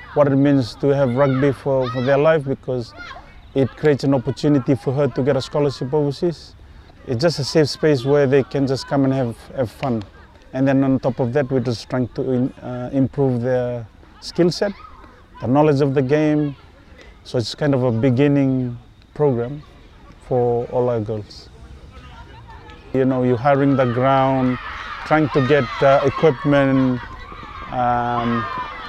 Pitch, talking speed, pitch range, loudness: 135 Hz, 165 wpm, 120-145 Hz, -19 LUFS